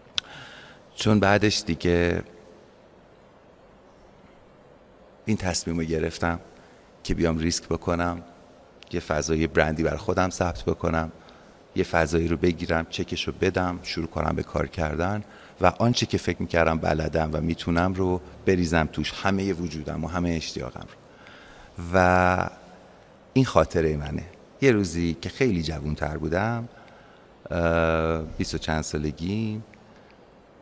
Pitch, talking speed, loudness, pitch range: 85 Hz, 120 wpm, -25 LUFS, 80-90 Hz